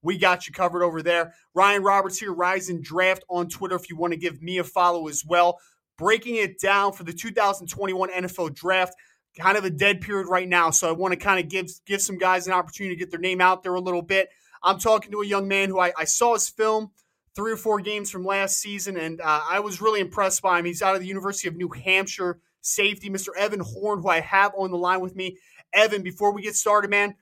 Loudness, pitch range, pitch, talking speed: -23 LUFS, 180-200 Hz, 190 Hz, 245 wpm